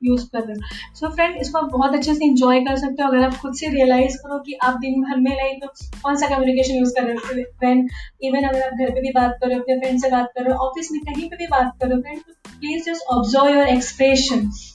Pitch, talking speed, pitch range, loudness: 260 Hz, 255 wpm, 255-280 Hz, -19 LUFS